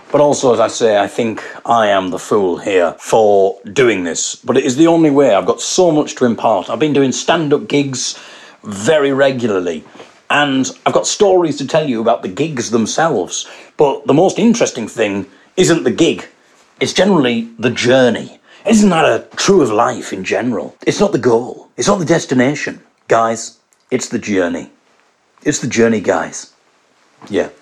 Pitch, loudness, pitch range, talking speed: 140 Hz, -14 LUFS, 120-165 Hz, 180 wpm